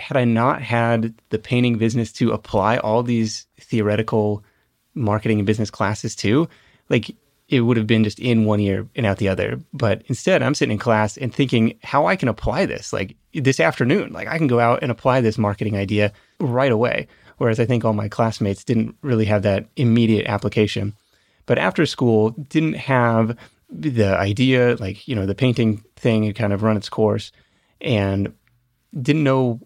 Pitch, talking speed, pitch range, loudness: 115 Hz, 185 wpm, 105-125 Hz, -20 LUFS